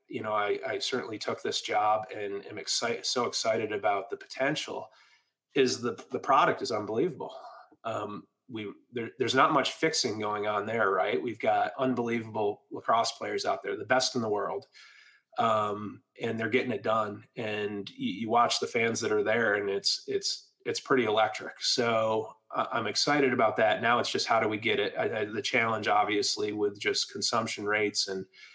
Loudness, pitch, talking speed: -29 LUFS, 115 Hz, 190 wpm